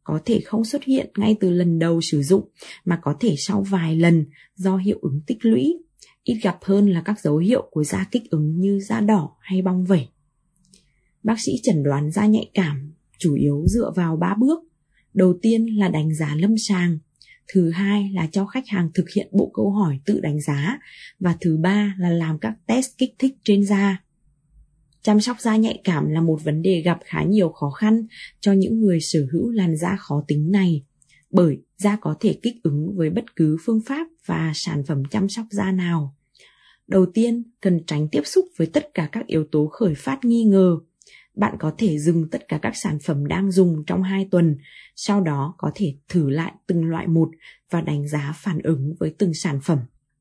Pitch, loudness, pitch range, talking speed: 180 Hz, -21 LUFS, 155-205 Hz, 210 wpm